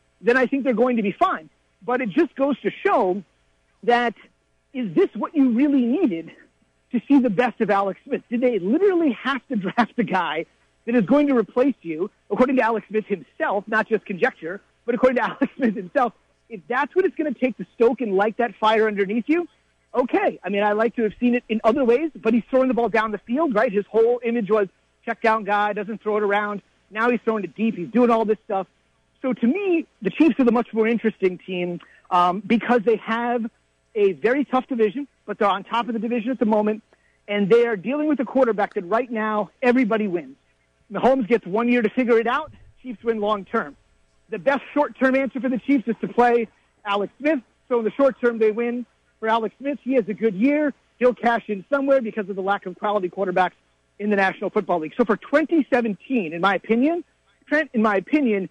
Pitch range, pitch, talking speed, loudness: 210-255 Hz, 230 Hz, 225 wpm, -22 LUFS